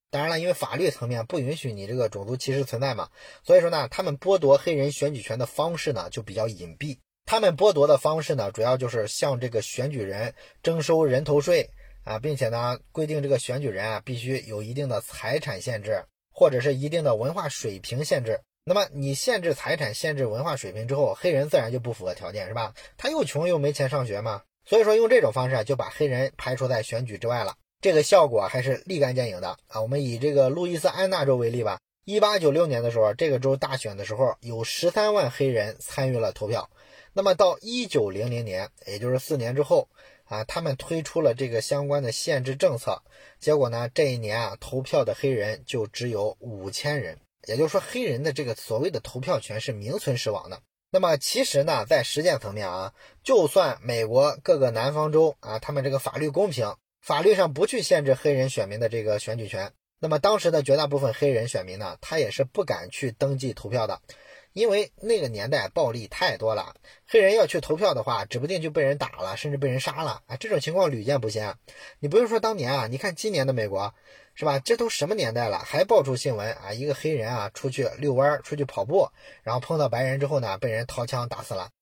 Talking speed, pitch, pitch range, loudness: 330 characters per minute, 135 Hz, 115-150 Hz, -25 LUFS